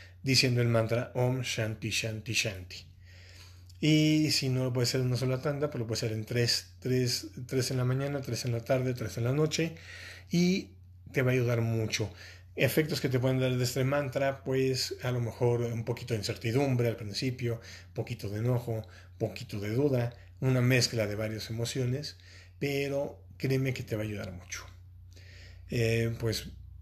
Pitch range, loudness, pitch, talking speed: 100-130 Hz, -31 LUFS, 115 Hz, 185 wpm